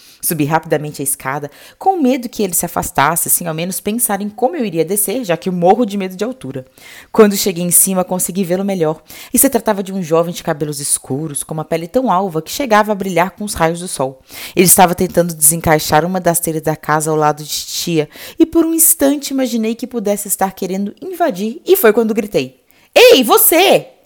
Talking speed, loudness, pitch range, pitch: 215 wpm, -14 LUFS, 160-230 Hz, 185 Hz